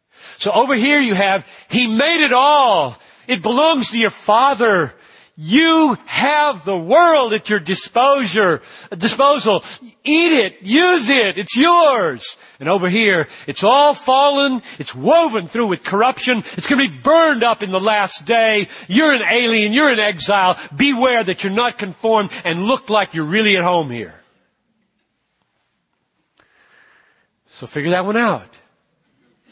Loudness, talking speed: -15 LUFS, 145 wpm